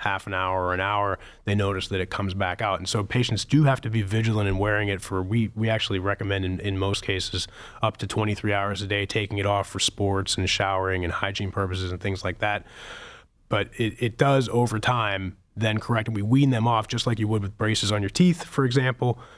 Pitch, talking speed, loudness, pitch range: 100 Hz, 240 wpm, -25 LUFS, 95-115 Hz